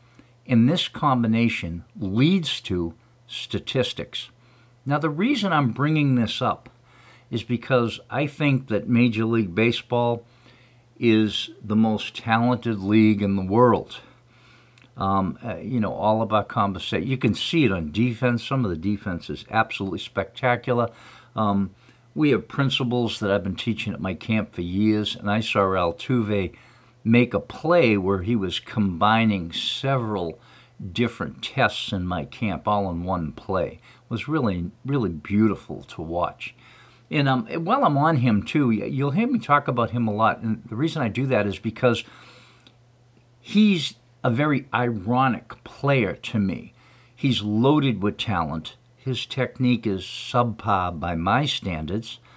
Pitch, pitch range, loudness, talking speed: 120 Hz, 105-125 Hz, -23 LUFS, 150 wpm